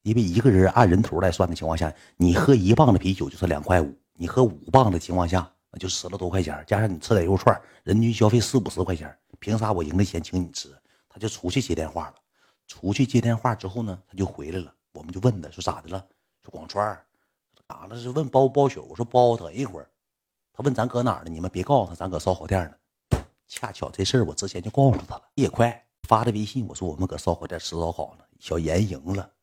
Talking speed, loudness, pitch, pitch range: 345 characters per minute, -24 LUFS, 95 Hz, 90-120 Hz